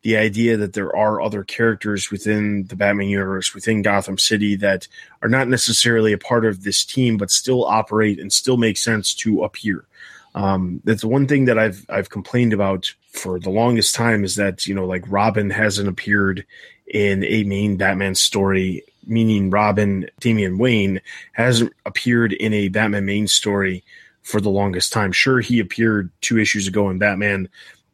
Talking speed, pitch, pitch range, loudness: 170 wpm, 105 Hz, 100-110 Hz, -18 LUFS